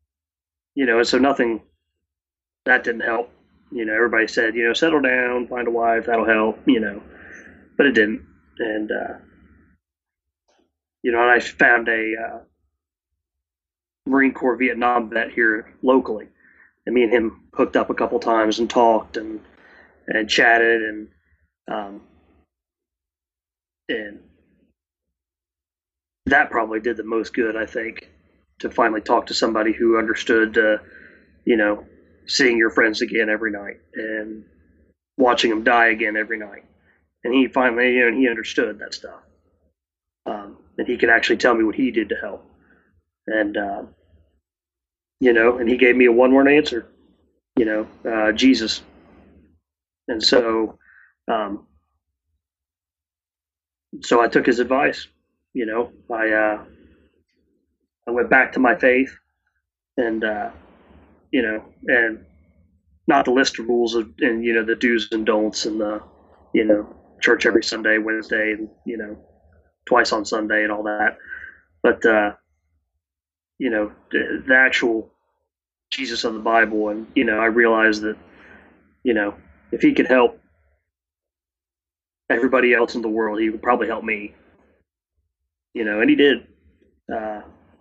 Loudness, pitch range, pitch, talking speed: -19 LUFS, 80-115 Hz, 105 Hz, 150 wpm